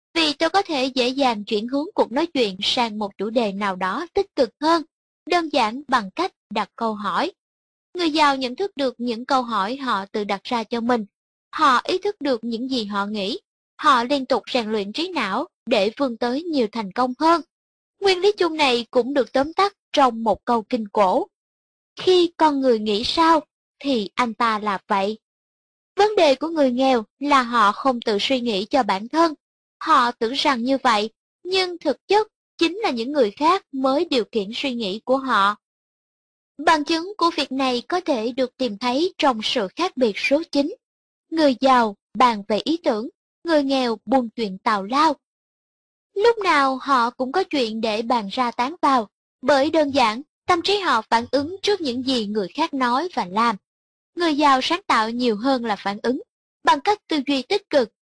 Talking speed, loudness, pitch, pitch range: 195 wpm, -21 LUFS, 265 Hz, 230-315 Hz